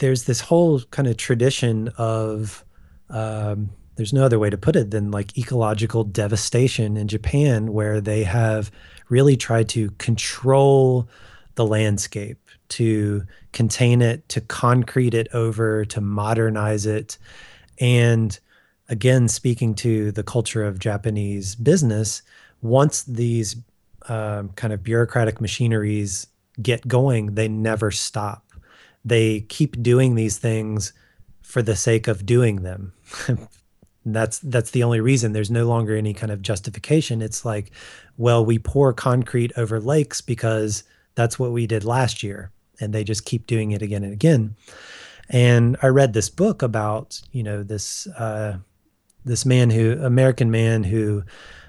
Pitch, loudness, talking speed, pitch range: 110 Hz, -21 LUFS, 145 wpm, 105-120 Hz